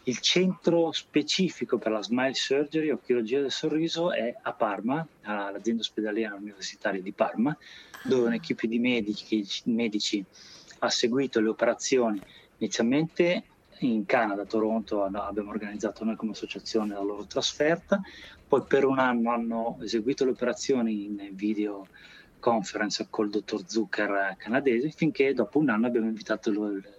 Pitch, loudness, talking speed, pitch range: 115 Hz, -28 LUFS, 140 wpm, 105-135 Hz